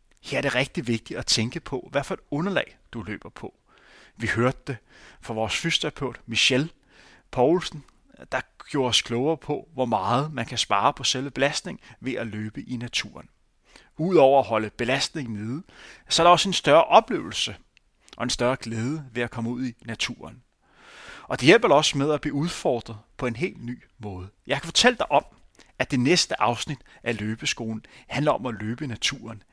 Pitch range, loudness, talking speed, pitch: 115-145 Hz, -24 LUFS, 190 wpm, 125 Hz